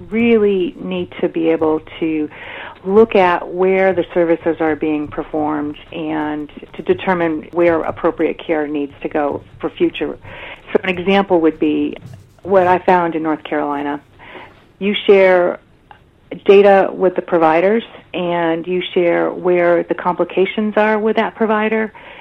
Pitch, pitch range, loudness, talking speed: 175 Hz, 155-190 Hz, -16 LUFS, 140 wpm